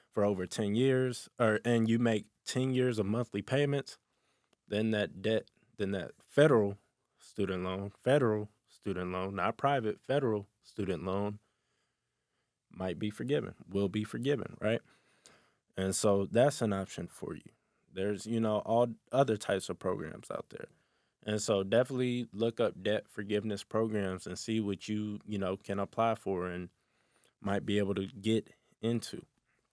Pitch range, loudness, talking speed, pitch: 100-115 Hz, -33 LUFS, 155 wpm, 105 Hz